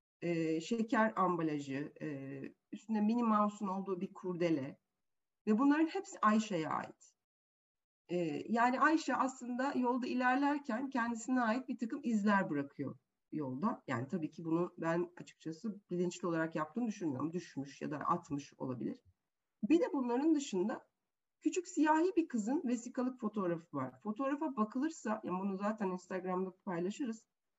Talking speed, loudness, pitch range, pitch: 135 wpm, -36 LUFS, 170-250 Hz, 210 Hz